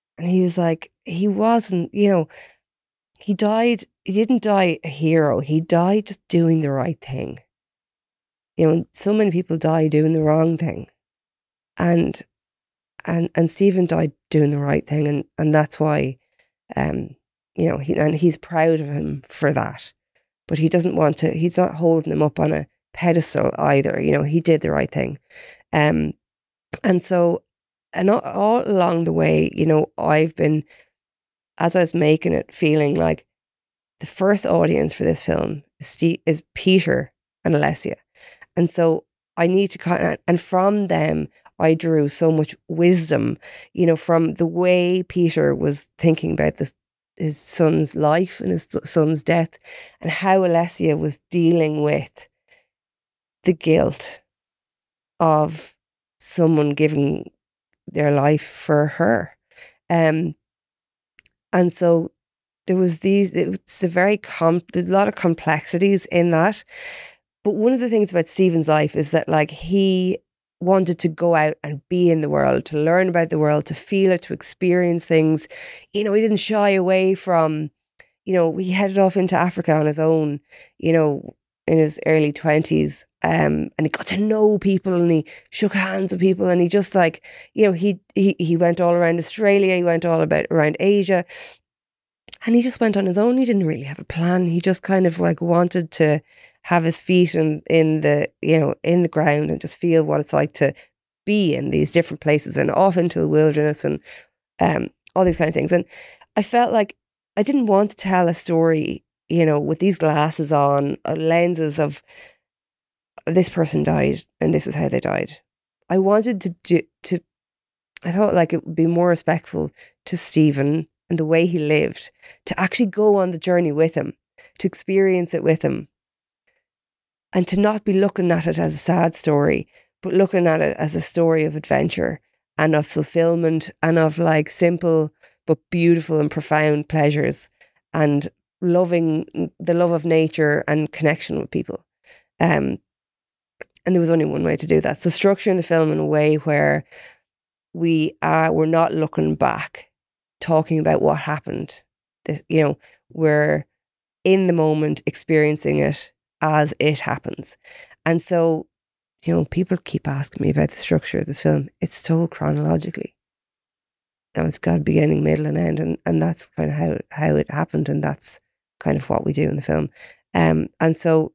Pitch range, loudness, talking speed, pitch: 155-180 Hz, -19 LUFS, 175 wpm, 165 Hz